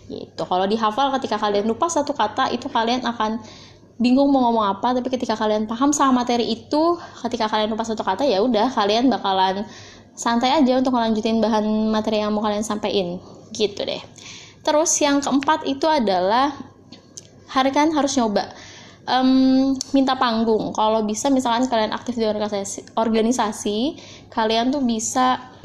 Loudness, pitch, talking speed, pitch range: -20 LUFS, 230 Hz, 150 wpm, 215-265 Hz